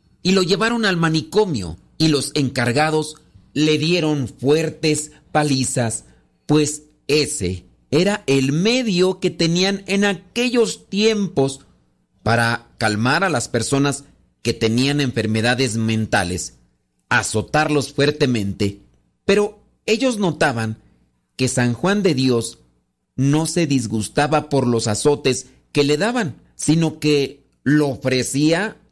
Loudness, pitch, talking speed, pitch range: -19 LUFS, 140 Hz, 110 wpm, 115-160 Hz